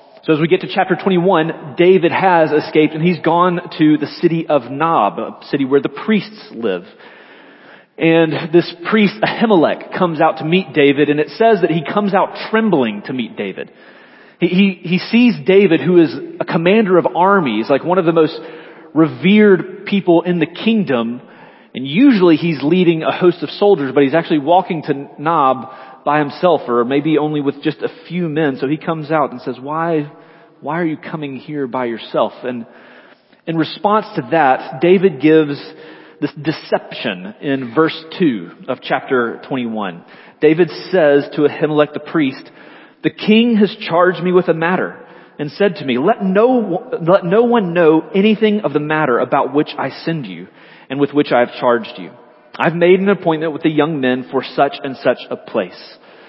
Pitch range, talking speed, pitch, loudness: 150-185 Hz, 185 wpm, 165 Hz, -15 LUFS